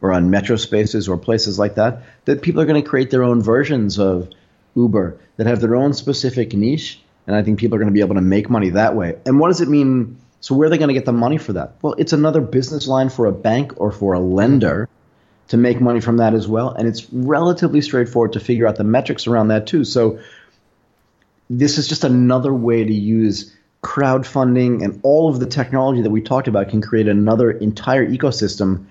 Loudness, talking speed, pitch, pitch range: -16 LUFS, 225 wpm, 115 Hz, 105-130 Hz